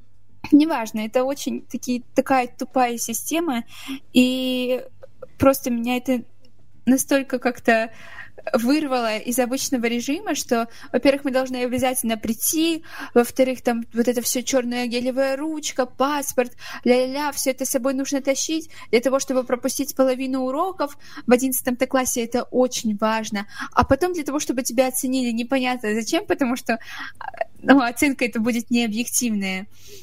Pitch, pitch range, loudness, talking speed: 260 Hz, 245-275 Hz, -22 LUFS, 135 wpm